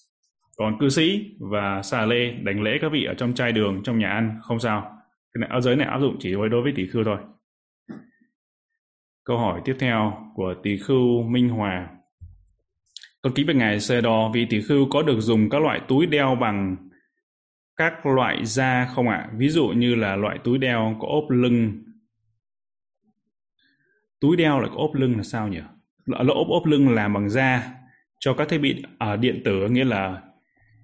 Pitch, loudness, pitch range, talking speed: 120 Hz, -22 LUFS, 105-135 Hz, 195 wpm